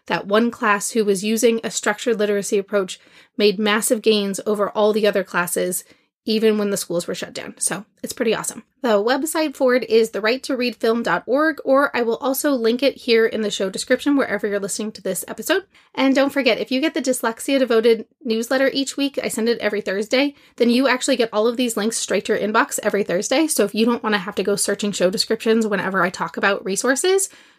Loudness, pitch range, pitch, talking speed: -20 LUFS, 205-255 Hz, 225 Hz, 220 wpm